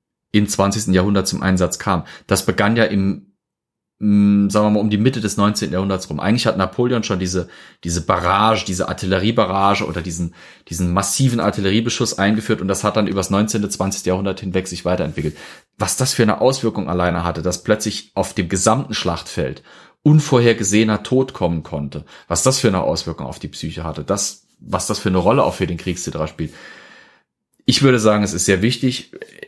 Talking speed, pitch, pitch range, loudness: 185 wpm, 100 Hz, 90-110 Hz, -18 LUFS